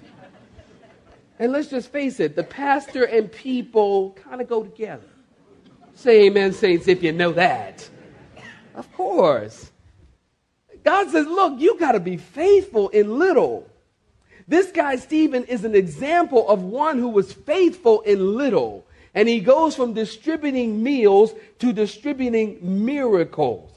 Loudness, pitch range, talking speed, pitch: -19 LUFS, 210-310 Hz, 135 wpm, 245 Hz